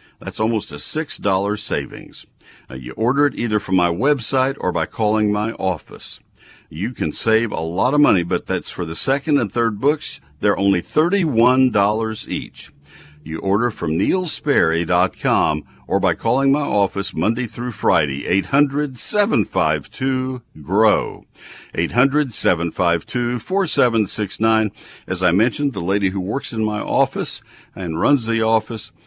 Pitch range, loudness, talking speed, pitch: 95-135 Hz, -19 LUFS, 140 wpm, 110 Hz